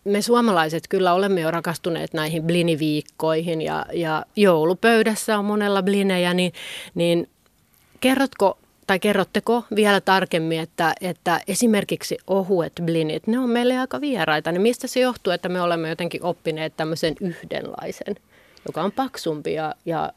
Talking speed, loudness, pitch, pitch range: 140 wpm, -22 LUFS, 180 Hz, 165-205 Hz